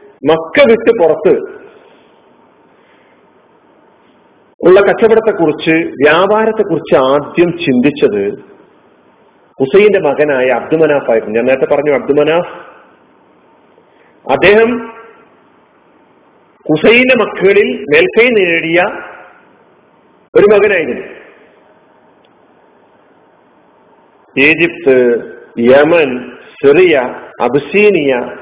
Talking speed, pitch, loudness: 65 wpm, 200 Hz, -10 LUFS